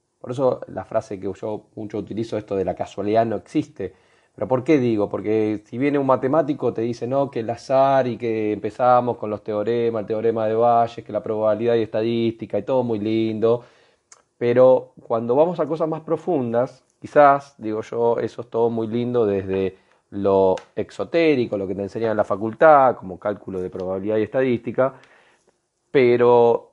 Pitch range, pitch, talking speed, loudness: 105-125 Hz, 115 Hz, 180 wpm, -21 LUFS